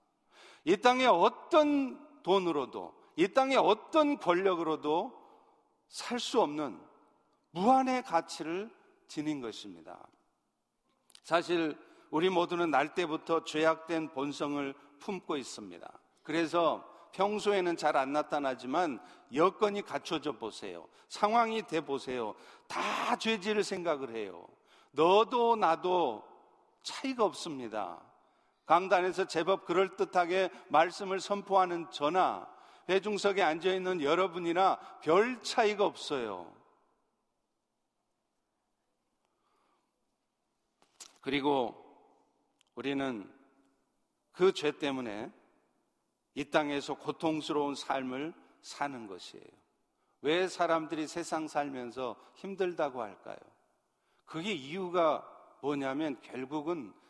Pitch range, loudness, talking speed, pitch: 150-215 Hz, -32 LUFS, 215 characters per minute, 180 Hz